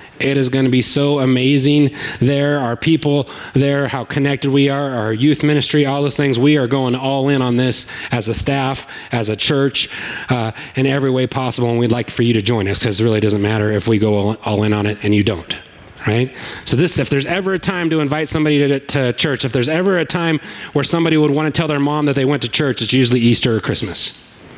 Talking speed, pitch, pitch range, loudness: 240 wpm, 135 Hz, 120-145 Hz, -16 LUFS